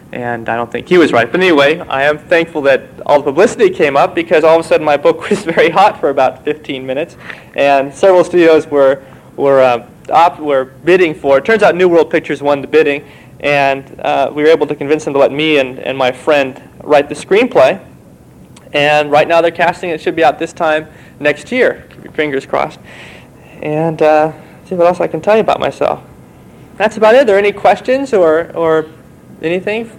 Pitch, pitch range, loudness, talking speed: 155 Hz, 140-170 Hz, -12 LUFS, 215 wpm